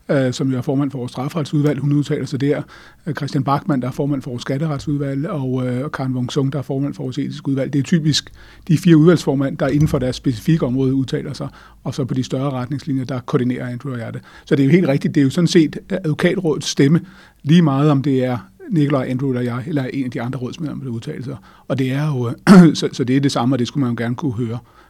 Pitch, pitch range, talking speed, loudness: 140 Hz, 130-150 Hz, 260 wpm, -18 LUFS